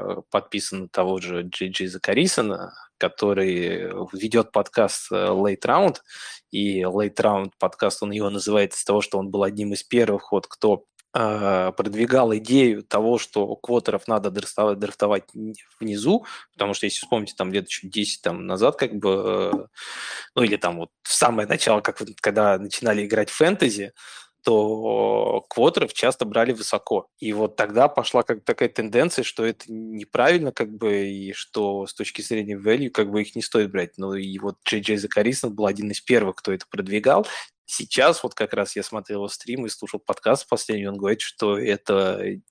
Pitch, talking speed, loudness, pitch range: 105 Hz, 175 wpm, -23 LUFS, 100-110 Hz